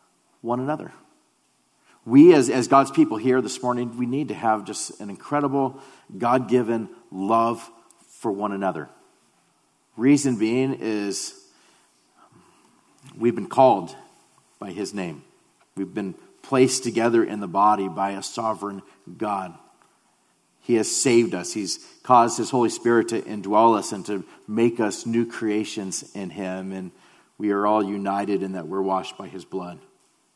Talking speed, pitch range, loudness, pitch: 150 wpm, 100-125 Hz, -22 LUFS, 115 Hz